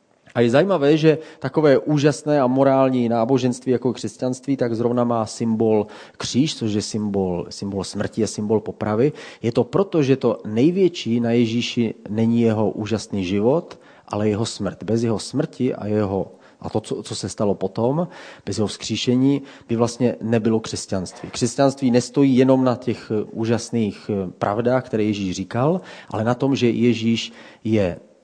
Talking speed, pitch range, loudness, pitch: 155 wpm, 105-130 Hz, -21 LUFS, 115 Hz